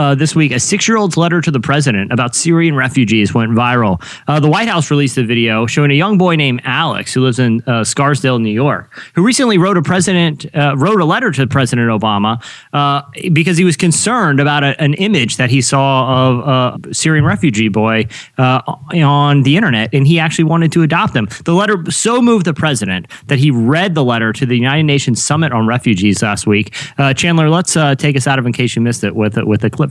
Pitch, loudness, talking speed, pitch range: 140 Hz, -12 LUFS, 225 wpm, 120-160 Hz